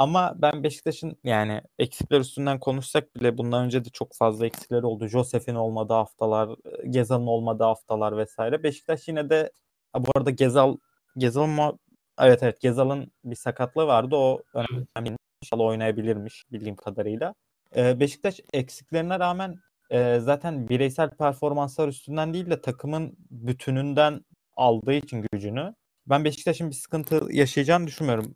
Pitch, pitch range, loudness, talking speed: 135 Hz, 120-150 Hz, -25 LUFS, 130 wpm